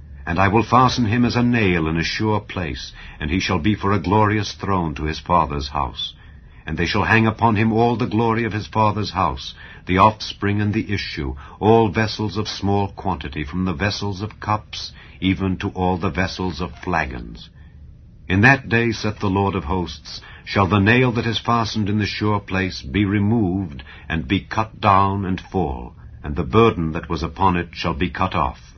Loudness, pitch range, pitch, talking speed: -20 LUFS, 85-105 Hz, 95 Hz, 200 wpm